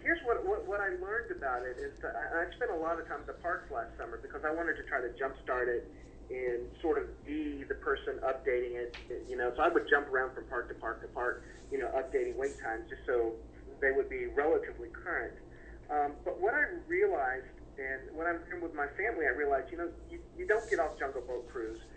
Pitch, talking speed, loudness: 350 Hz, 240 wpm, -35 LUFS